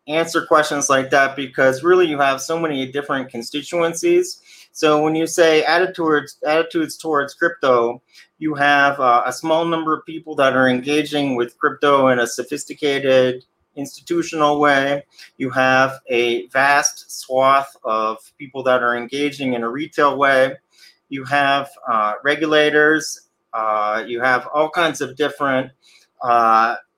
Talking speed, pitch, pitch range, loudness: 140 wpm, 140 Hz, 130-155 Hz, -18 LUFS